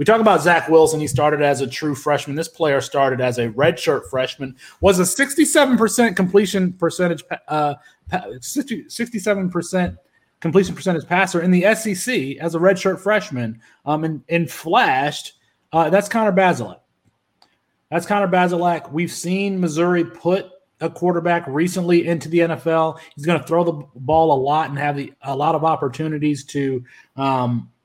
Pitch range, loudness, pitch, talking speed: 150-185 Hz, -19 LUFS, 170 Hz, 160 wpm